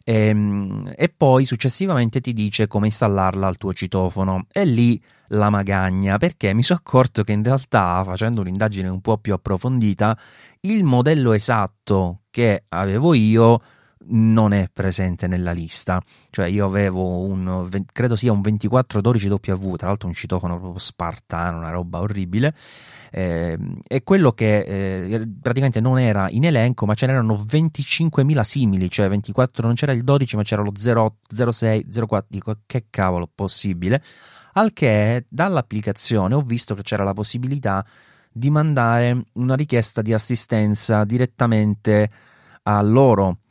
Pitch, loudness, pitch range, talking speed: 110 Hz, -20 LUFS, 100-125 Hz, 145 wpm